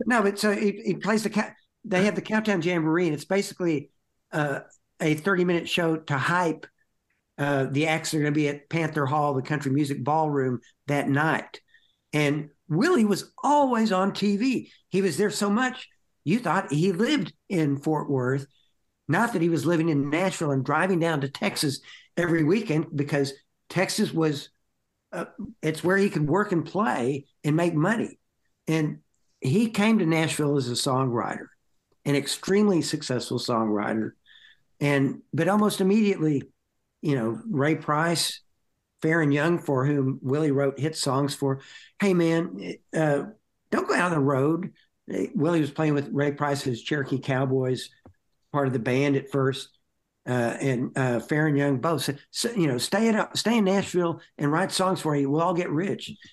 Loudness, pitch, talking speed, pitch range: -25 LUFS, 155 Hz, 175 wpm, 140-185 Hz